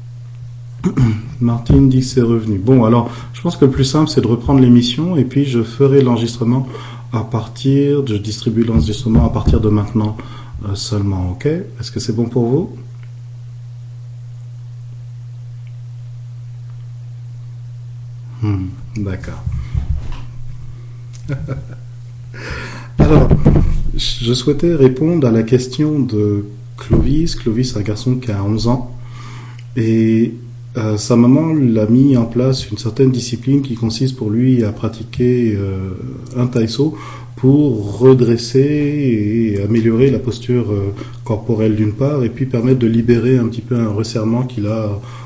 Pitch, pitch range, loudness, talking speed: 120 Hz, 115-125 Hz, -15 LUFS, 130 wpm